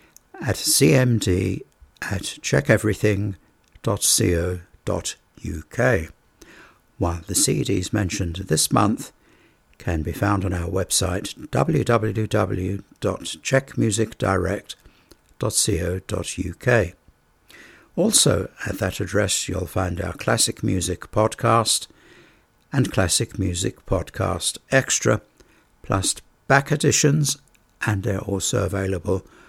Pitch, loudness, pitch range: 100 Hz, -22 LUFS, 90-110 Hz